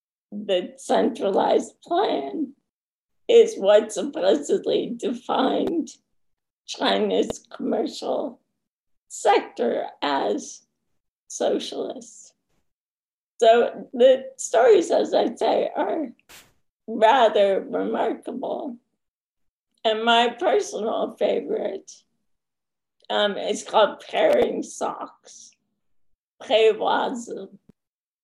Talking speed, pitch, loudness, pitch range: 65 wpm, 250 Hz, -22 LUFS, 220-360 Hz